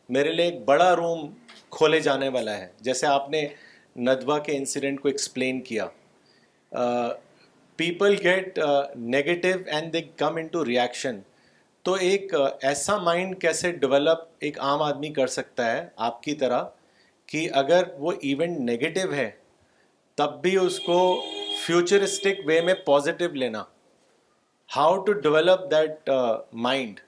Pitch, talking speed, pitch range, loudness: 155 Hz, 135 wpm, 140-175 Hz, -24 LUFS